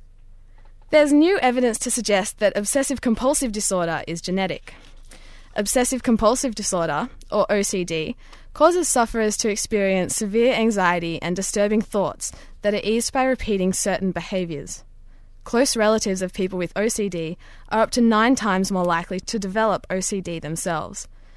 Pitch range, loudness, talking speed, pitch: 175-230 Hz, -21 LUFS, 140 wpm, 205 Hz